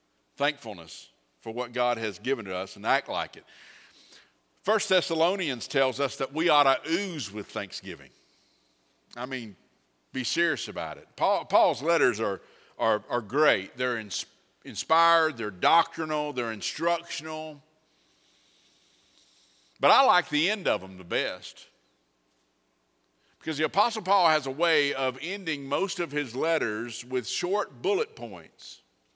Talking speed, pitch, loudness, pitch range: 140 wpm, 135 Hz, -27 LUFS, 105-165 Hz